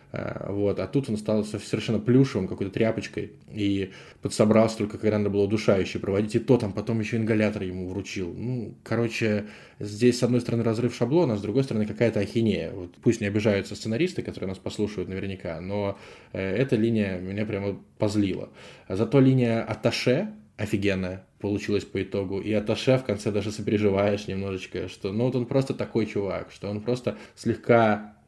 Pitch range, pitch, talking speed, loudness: 100-115 Hz, 105 Hz, 170 wpm, -26 LUFS